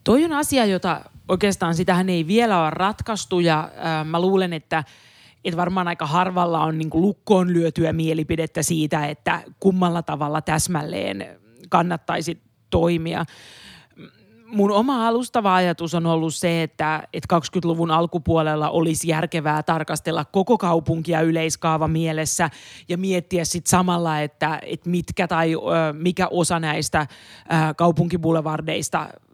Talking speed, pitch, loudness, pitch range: 130 wpm, 170 Hz, -21 LUFS, 160-180 Hz